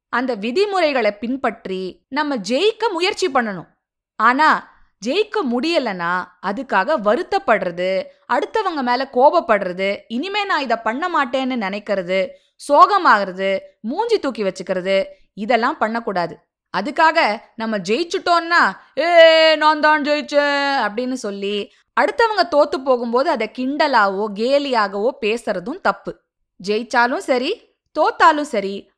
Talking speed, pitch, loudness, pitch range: 100 wpm, 255 Hz, -18 LUFS, 210-315 Hz